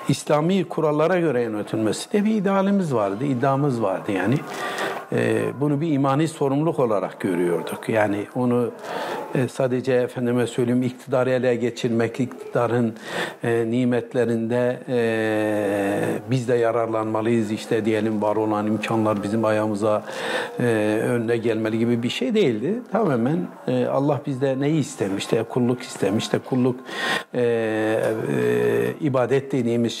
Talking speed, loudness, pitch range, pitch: 120 wpm, -22 LUFS, 110-135 Hz, 120 Hz